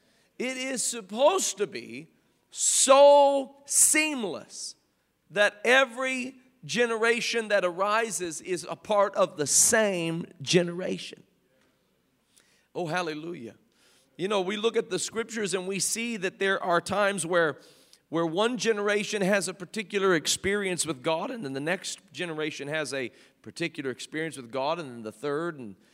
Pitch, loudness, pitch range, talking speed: 190 Hz, -26 LUFS, 165-230 Hz, 140 wpm